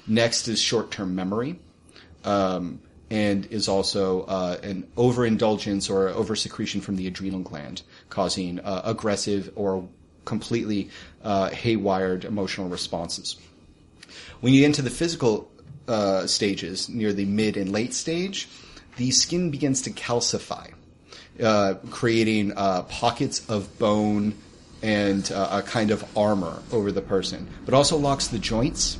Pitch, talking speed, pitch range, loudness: 100 Hz, 135 wpm, 95-115 Hz, -25 LUFS